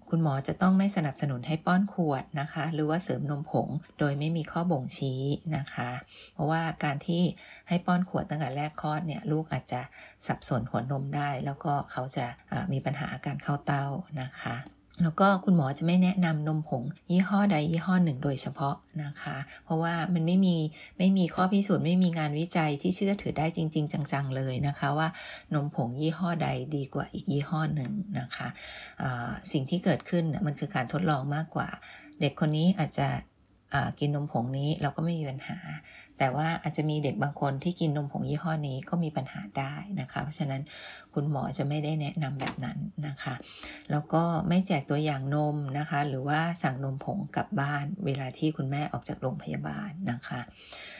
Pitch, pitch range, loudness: 155 Hz, 140-170 Hz, -30 LUFS